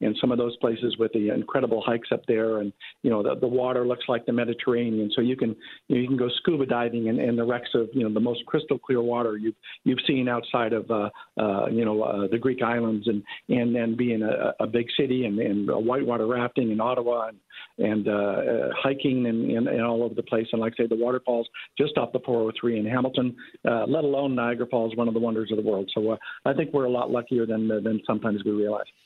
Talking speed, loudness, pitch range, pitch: 250 wpm, -26 LUFS, 110-125 Hz, 120 Hz